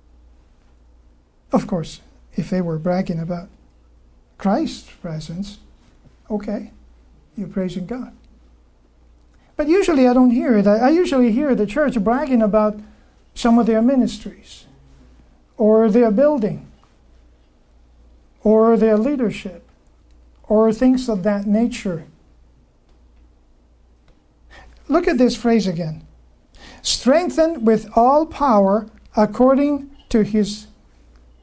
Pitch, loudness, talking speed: 200 Hz, -18 LUFS, 100 wpm